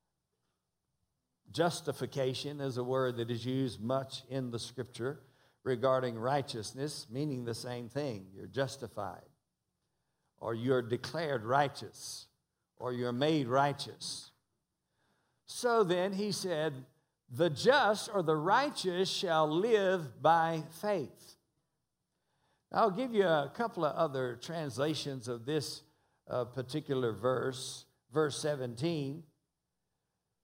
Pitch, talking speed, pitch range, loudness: 140 Hz, 110 wpm, 125-160 Hz, -34 LUFS